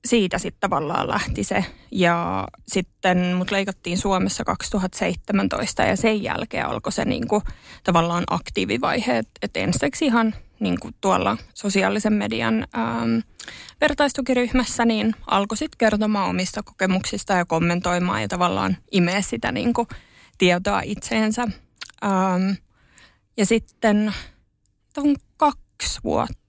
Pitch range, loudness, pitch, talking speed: 180-225 Hz, -22 LUFS, 200 Hz, 110 wpm